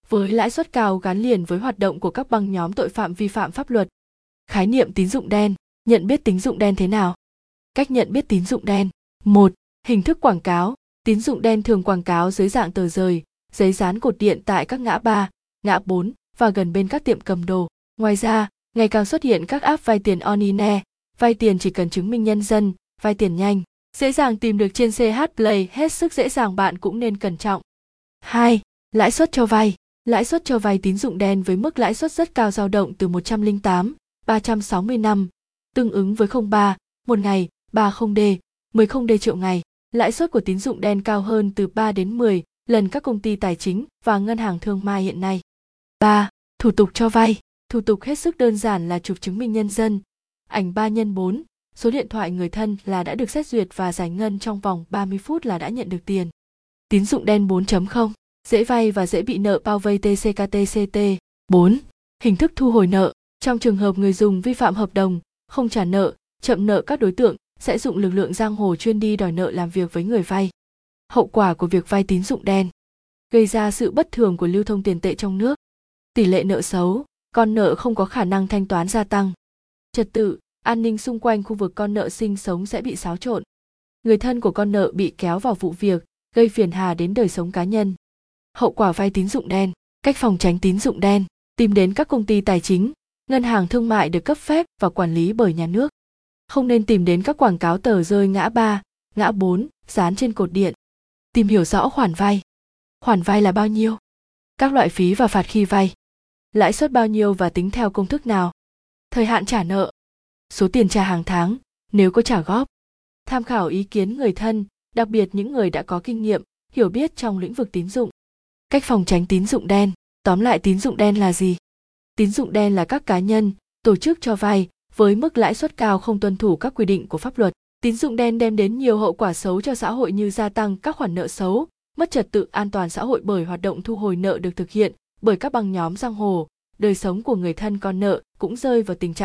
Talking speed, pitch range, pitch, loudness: 230 wpm, 190-230 Hz, 210 Hz, -20 LUFS